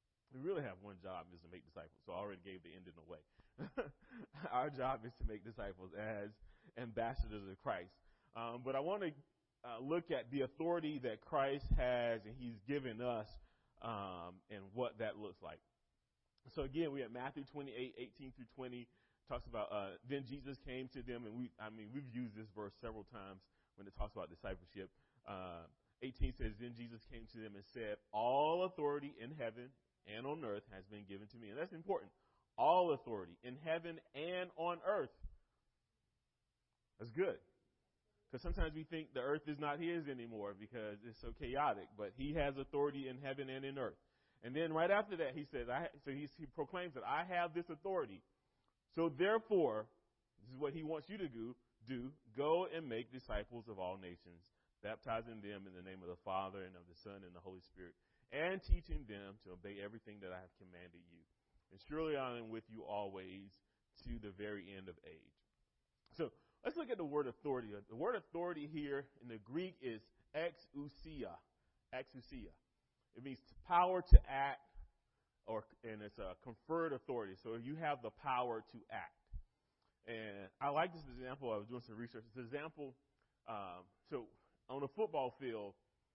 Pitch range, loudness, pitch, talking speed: 105-145 Hz, -44 LUFS, 120 Hz, 185 wpm